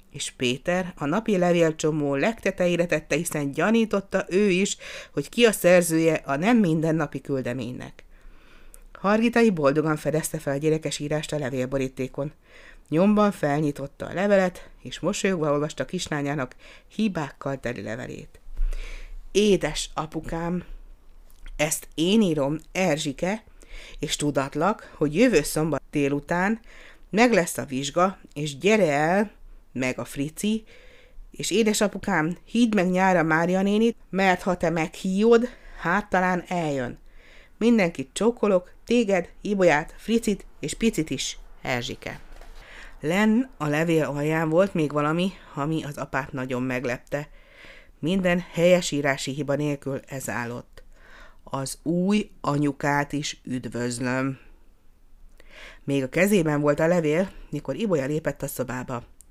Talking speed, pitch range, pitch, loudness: 120 wpm, 140-190 Hz, 155 Hz, -24 LUFS